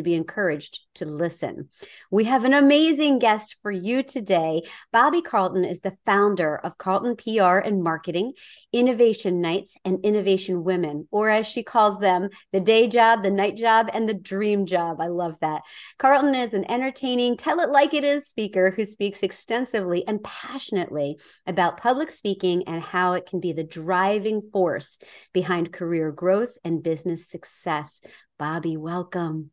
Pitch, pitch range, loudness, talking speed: 195 Hz, 175-230 Hz, -23 LUFS, 165 wpm